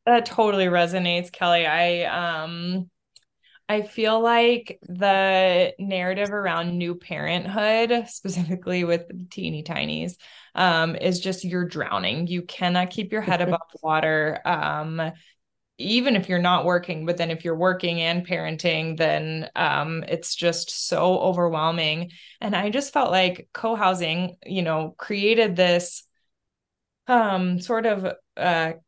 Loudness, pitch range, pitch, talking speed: -23 LUFS, 170-195 Hz, 180 Hz, 135 wpm